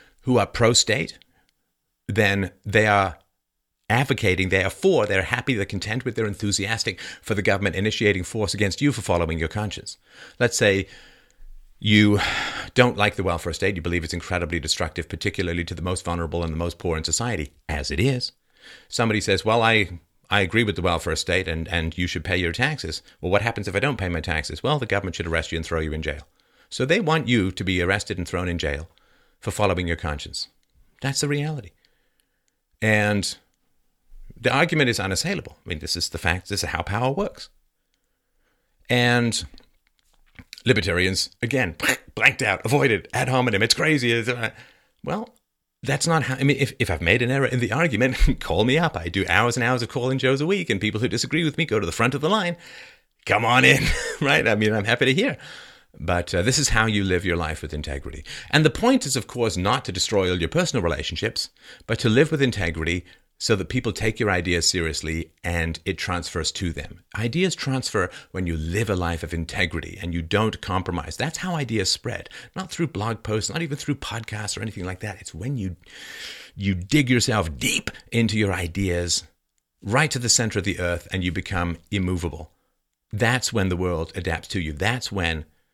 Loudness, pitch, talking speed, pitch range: -23 LUFS, 100 Hz, 200 wpm, 85-120 Hz